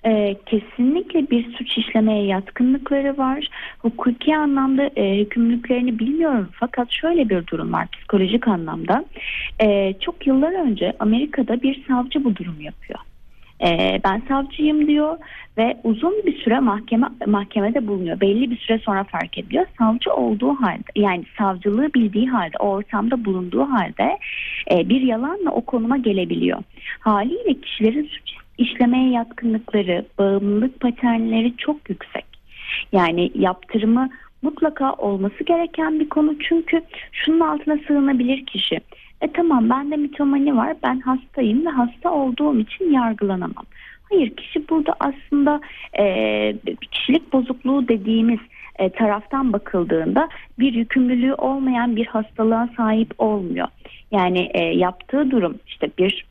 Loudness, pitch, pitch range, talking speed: -20 LUFS, 245 Hz, 210-280 Hz, 125 wpm